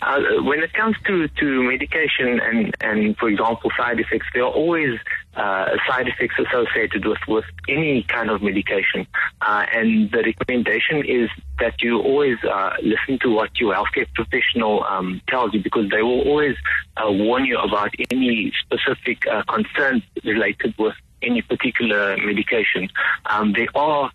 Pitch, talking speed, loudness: 145 Hz, 160 wpm, -20 LUFS